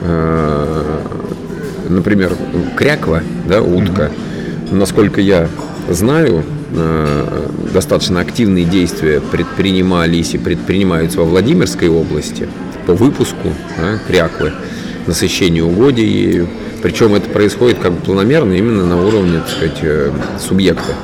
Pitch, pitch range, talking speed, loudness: 85 Hz, 80-95 Hz, 95 wpm, -13 LUFS